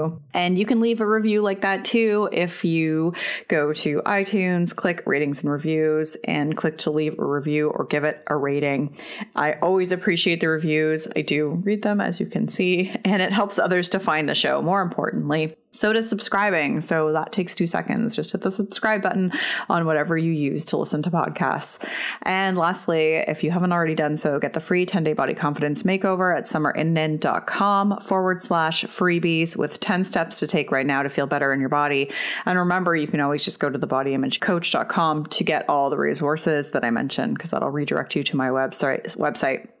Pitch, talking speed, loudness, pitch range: 165 Hz, 205 wpm, -22 LUFS, 150-195 Hz